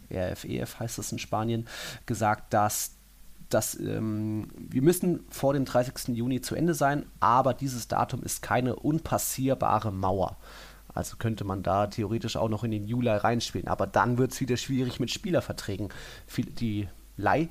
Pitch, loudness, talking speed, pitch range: 115 Hz, -29 LUFS, 160 wpm, 105-130 Hz